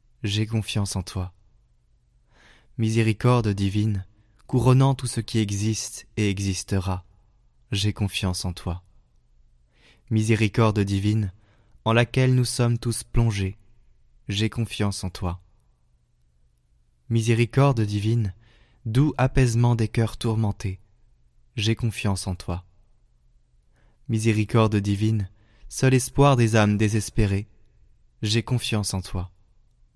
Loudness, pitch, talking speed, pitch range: -24 LUFS, 110 Hz, 100 wpm, 95-115 Hz